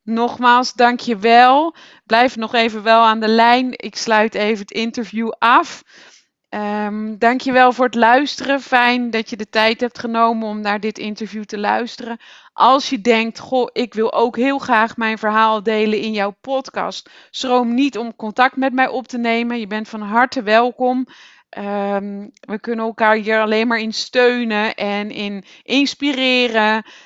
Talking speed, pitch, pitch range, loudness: 165 wpm, 230 Hz, 220-250 Hz, -16 LUFS